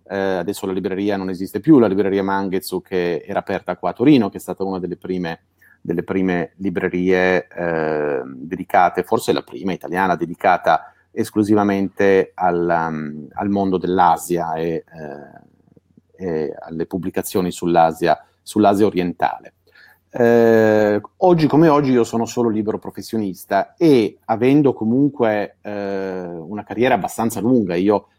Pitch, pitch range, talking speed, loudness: 95 Hz, 90-110 Hz, 135 wpm, -18 LUFS